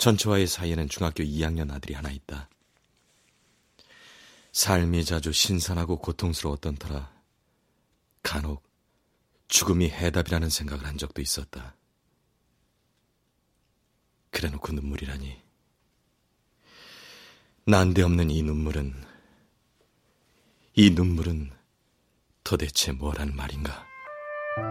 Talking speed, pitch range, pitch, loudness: 205 characters per minute, 70-90 Hz, 80 Hz, -26 LUFS